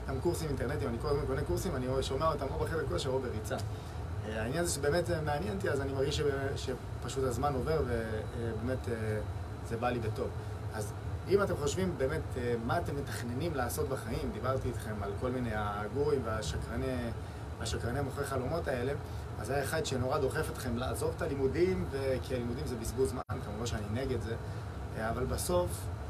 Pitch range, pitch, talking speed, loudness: 105-130 Hz, 115 Hz, 165 wpm, -35 LUFS